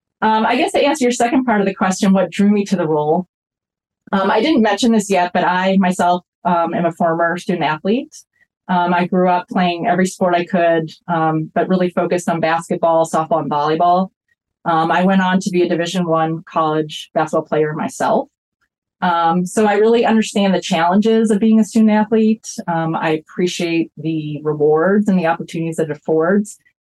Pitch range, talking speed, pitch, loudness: 165-210 Hz, 190 wpm, 180 Hz, -16 LUFS